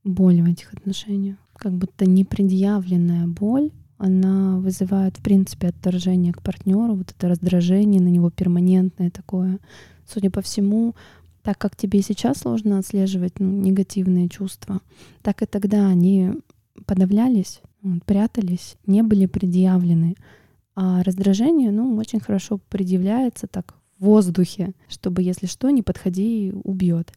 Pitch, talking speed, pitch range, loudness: 190 Hz, 135 wpm, 185-205 Hz, -20 LUFS